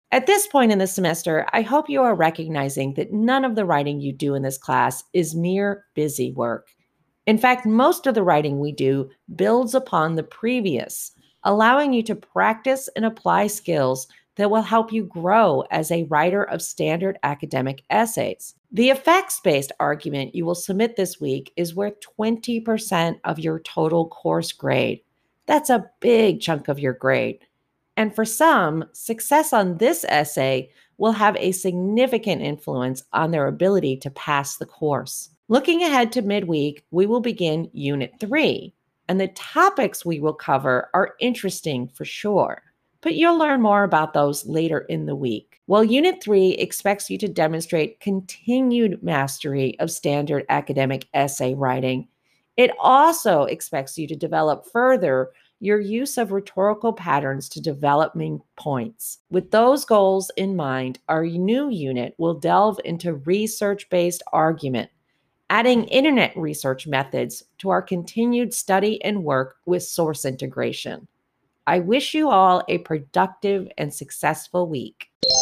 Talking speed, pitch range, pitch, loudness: 155 wpm, 145-220 Hz, 180 Hz, -21 LUFS